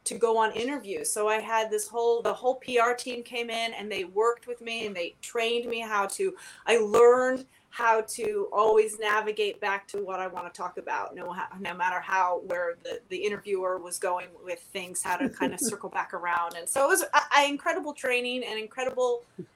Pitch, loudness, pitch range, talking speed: 225 Hz, -28 LUFS, 195-250 Hz, 210 wpm